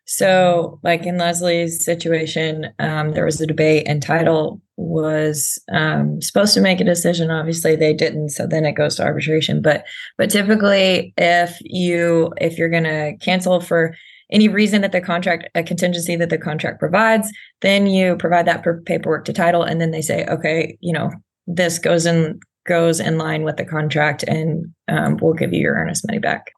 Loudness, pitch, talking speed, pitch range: -17 LUFS, 170 Hz, 185 wpm, 155-175 Hz